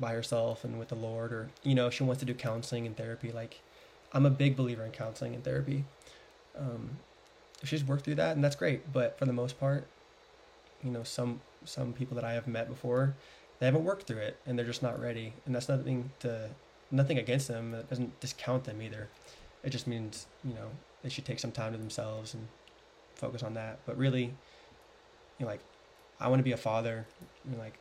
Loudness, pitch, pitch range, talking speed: -35 LUFS, 125 Hz, 115-135 Hz, 220 wpm